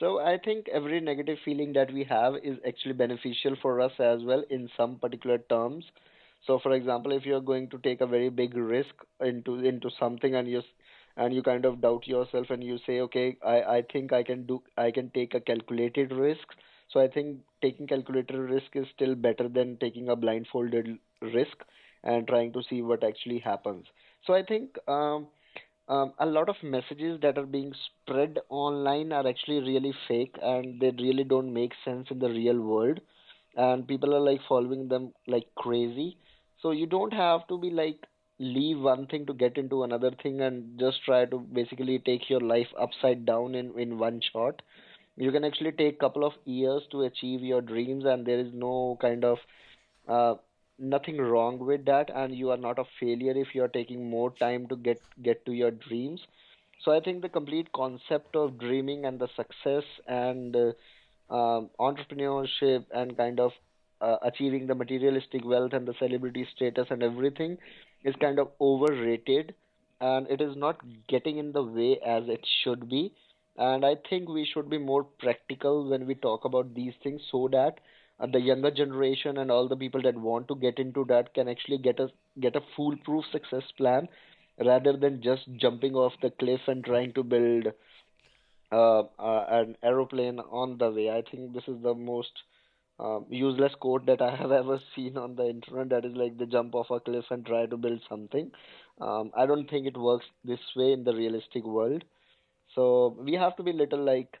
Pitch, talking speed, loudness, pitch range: 130 Hz, 195 wpm, -29 LUFS, 120-140 Hz